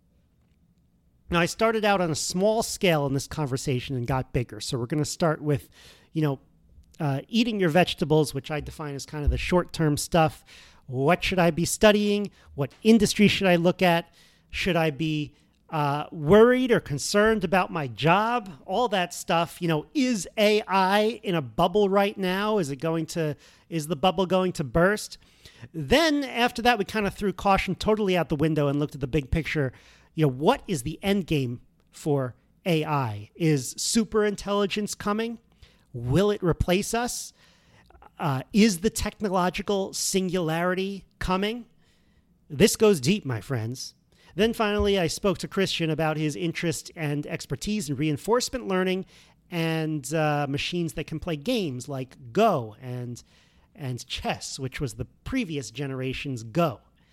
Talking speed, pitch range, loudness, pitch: 165 wpm, 145-200 Hz, -25 LUFS, 170 Hz